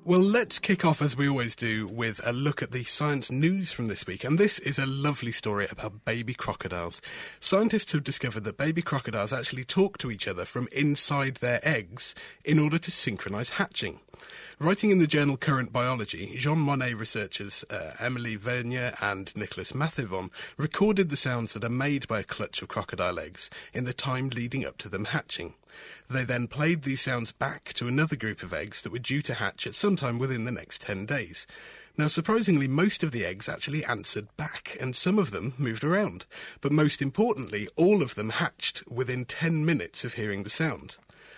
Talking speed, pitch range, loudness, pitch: 195 wpm, 115-150 Hz, -28 LUFS, 130 Hz